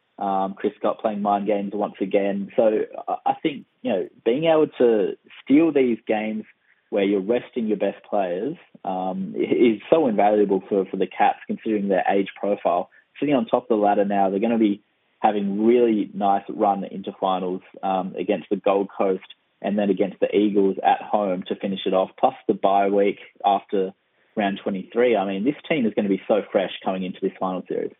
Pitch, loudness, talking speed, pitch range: 100 Hz, -22 LUFS, 195 wpm, 95-110 Hz